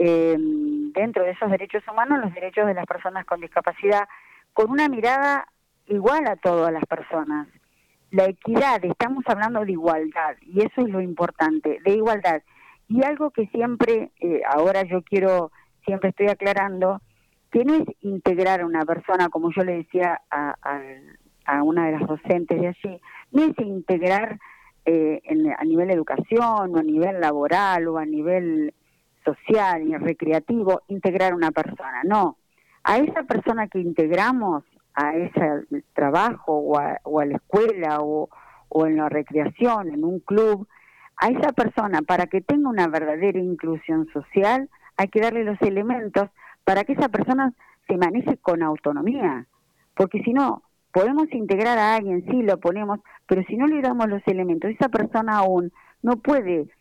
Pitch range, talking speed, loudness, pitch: 165-225 Hz, 165 wpm, -22 LUFS, 190 Hz